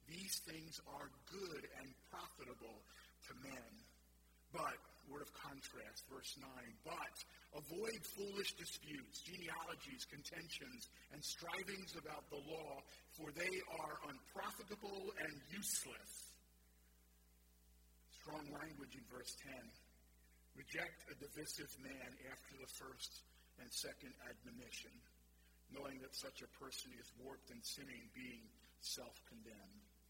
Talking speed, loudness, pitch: 115 wpm, -51 LUFS, 145 Hz